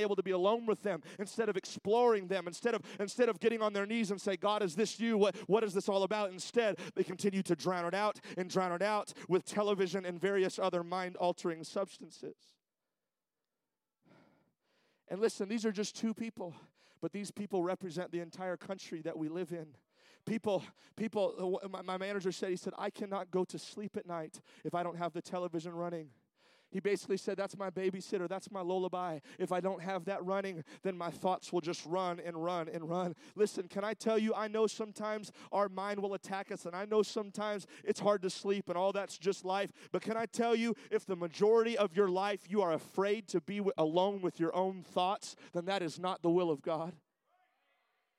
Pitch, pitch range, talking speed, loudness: 195 Hz, 180-205 Hz, 210 wpm, -36 LUFS